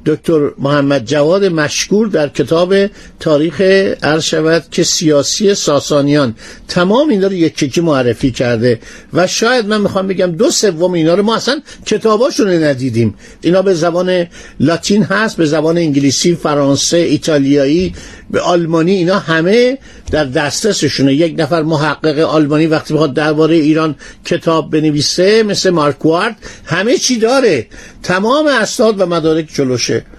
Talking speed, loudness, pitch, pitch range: 135 wpm, -12 LUFS, 165 Hz, 150-190 Hz